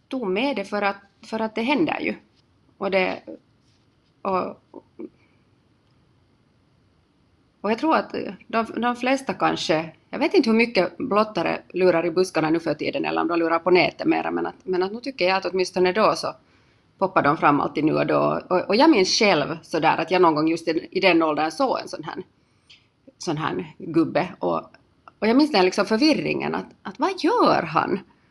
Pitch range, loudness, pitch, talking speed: 165-240 Hz, -22 LUFS, 190 Hz, 195 wpm